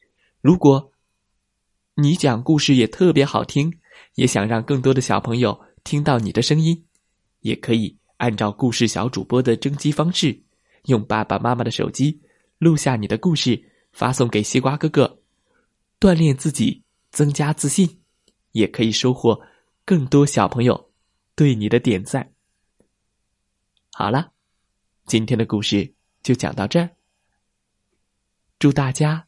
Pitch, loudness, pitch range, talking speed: 130 Hz, -19 LUFS, 110-150 Hz, 205 characters per minute